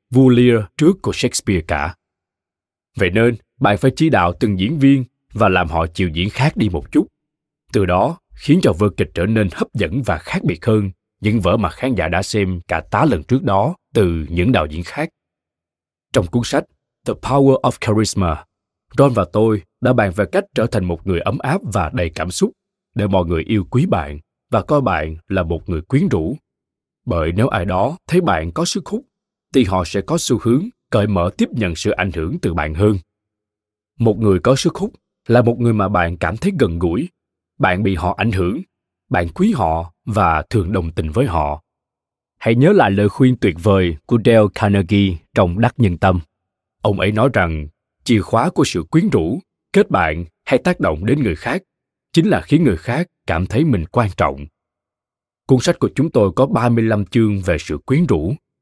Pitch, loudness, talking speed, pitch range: 105 Hz, -17 LUFS, 205 wpm, 90-120 Hz